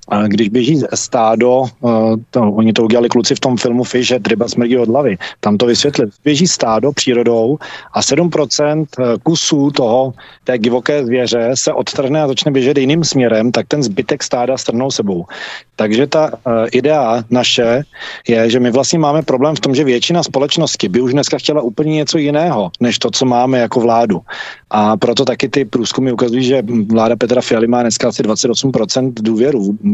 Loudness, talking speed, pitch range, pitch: -13 LUFS, 175 wpm, 115-140 Hz, 125 Hz